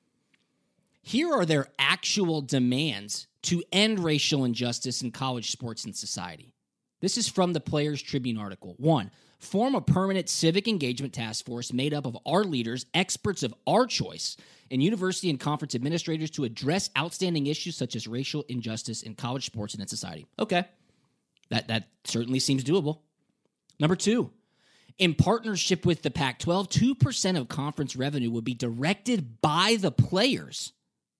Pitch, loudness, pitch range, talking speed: 150 Hz, -28 LUFS, 125-180 Hz, 155 wpm